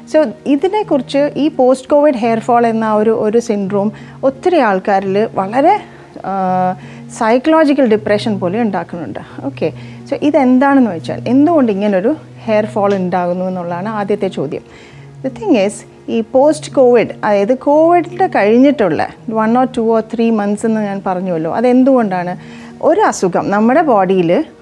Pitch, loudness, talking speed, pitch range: 225 Hz, -13 LUFS, 125 wpm, 190-270 Hz